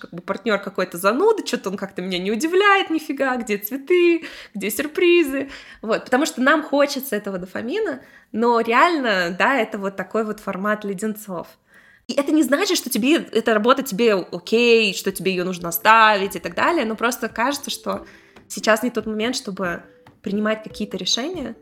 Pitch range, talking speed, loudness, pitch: 200-275 Hz, 170 wpm, -20 LUFS, 225 Hz